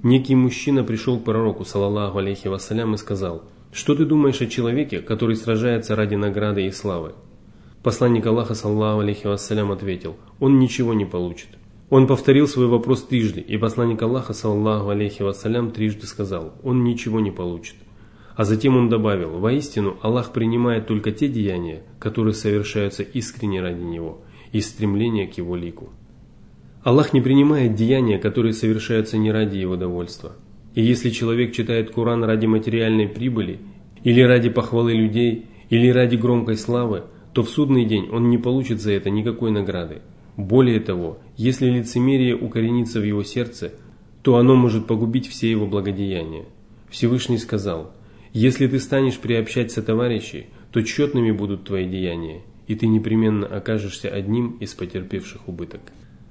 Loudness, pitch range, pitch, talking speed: -20 LUFS, 105-120 Hz, 110 Hz, 150 wpm